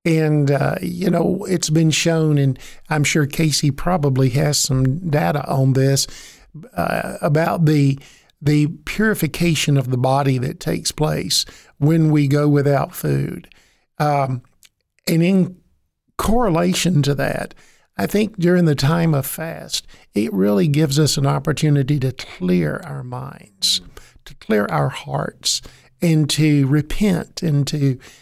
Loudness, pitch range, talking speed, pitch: -18 LUFS, 140-165 Hz, 140 wpm, 150 Hz